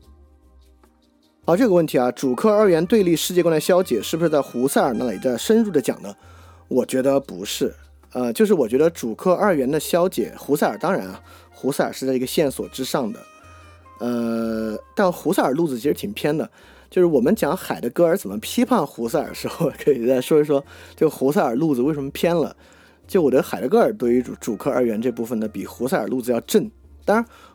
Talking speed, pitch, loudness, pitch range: 320 characters per minute, 130 Hz, -21 LUFS, 100-170 Hz